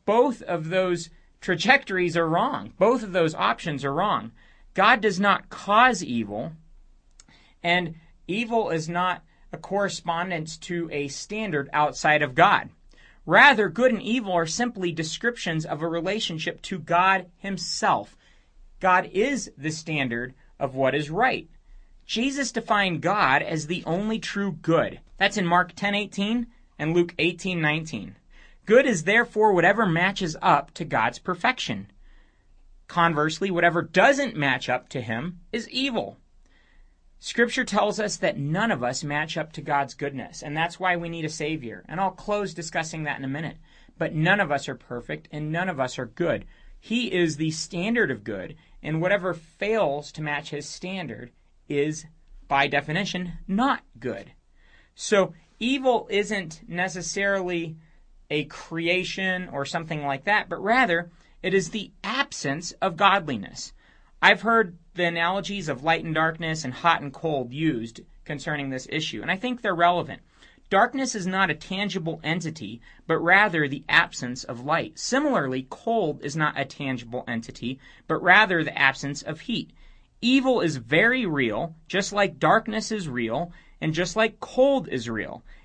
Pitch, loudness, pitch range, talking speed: 170 Hz, -24 LUFS, 150-200 Hz, 155 wpm